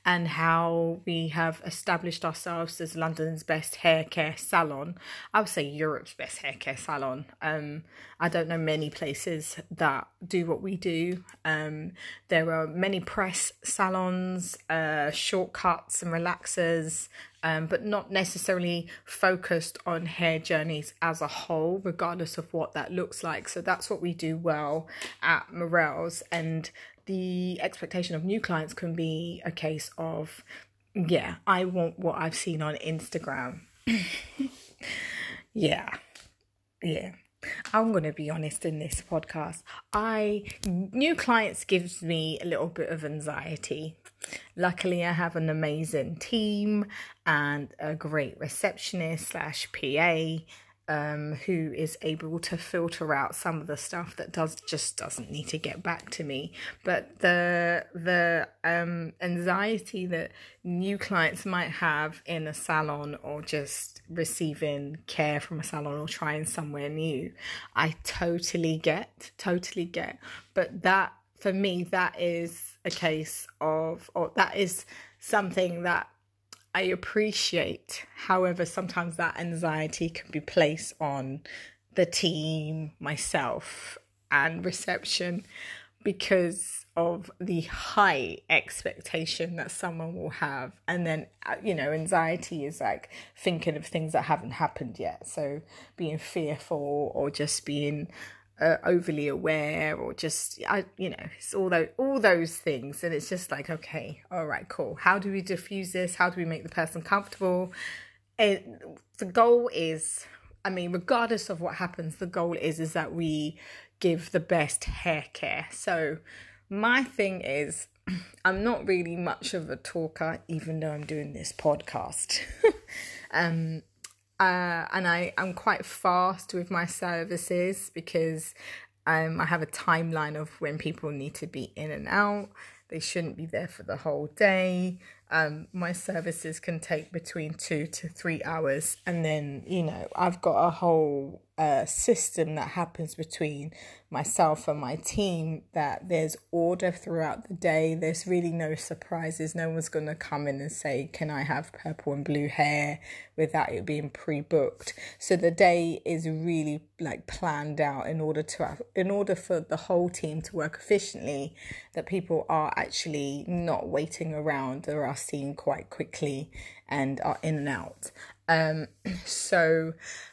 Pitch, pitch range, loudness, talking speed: 165 Hz, 155-180 Hz, -29 LUFS, 150 wpm